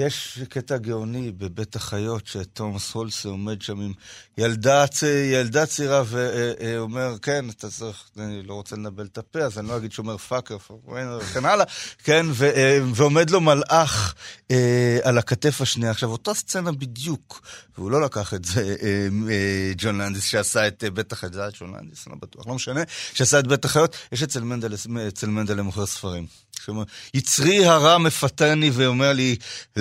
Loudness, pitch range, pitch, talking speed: -22 LUFS, 105-140 Hz, 120 Hz, 175 wpm